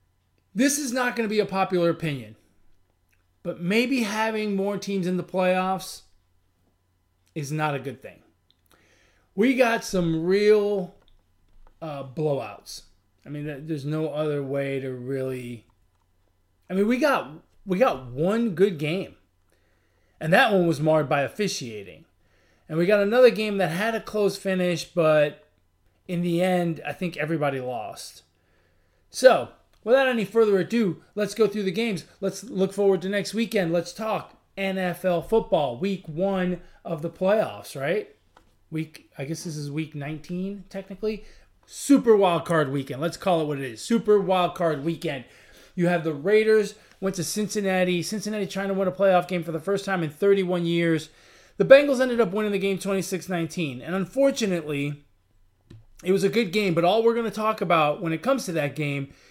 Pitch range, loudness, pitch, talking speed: 140-200 Hz, -24 LUFS, 175 Hz, 170 wpm